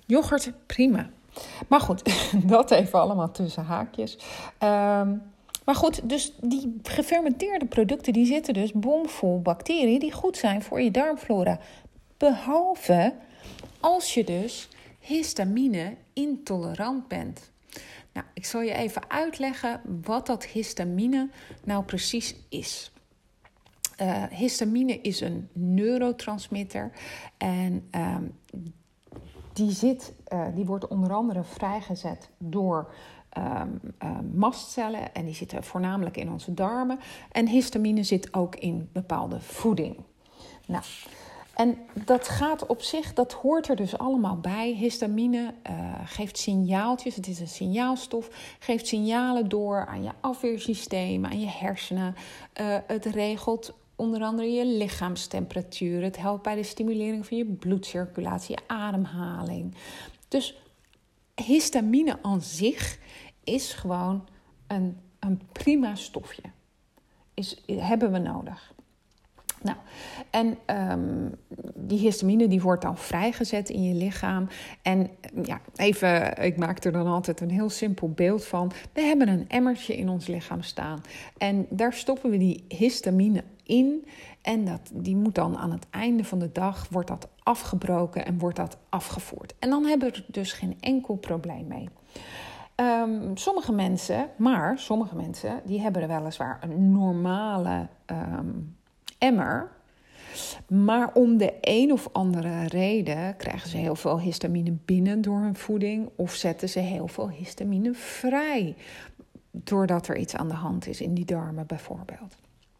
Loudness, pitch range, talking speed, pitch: -27 LUFS, 185-240 Hz, 135 wpm, 205 Hz